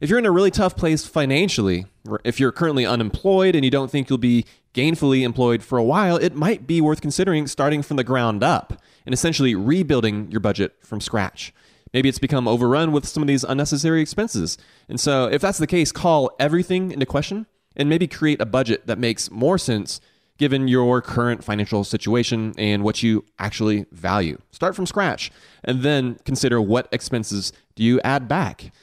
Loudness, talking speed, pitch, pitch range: -20 LUFS, 190 wpm, 130 Hz, 110-155 Hz